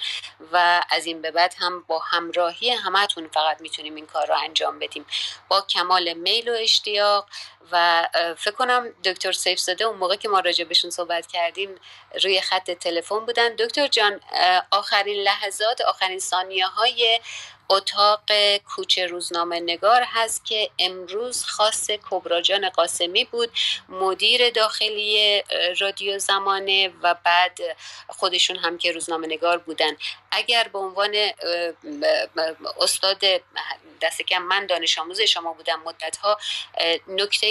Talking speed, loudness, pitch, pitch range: 130 wpm, -21 LUFS, 190 Hz, 175-215 Hz